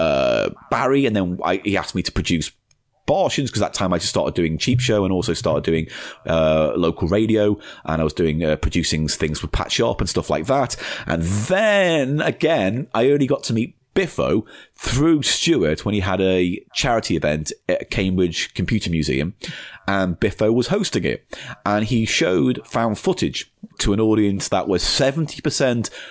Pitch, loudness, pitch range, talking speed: 105 Hz, -20 LUFS, 85-130 Hz, 180 wpm